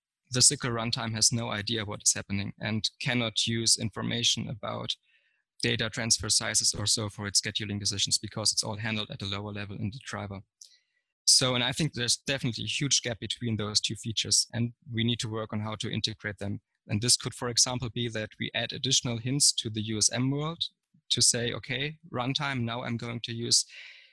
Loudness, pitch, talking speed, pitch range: -27 LUFS, 115 Hz, 200 wpm, 110-125 Hz